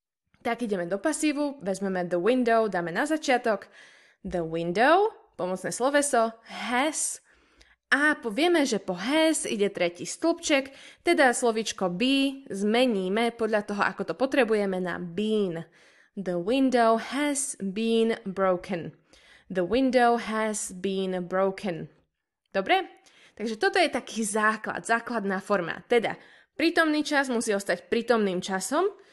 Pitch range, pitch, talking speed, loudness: 195-275 Hz, 225 Hz, 120 wpm, -26 LUFS